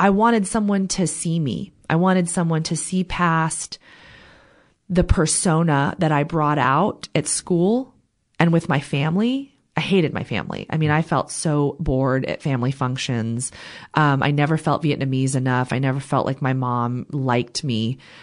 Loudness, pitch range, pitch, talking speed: -21 LUFS, 135-175 Hz, 155 Hz, 170 wpm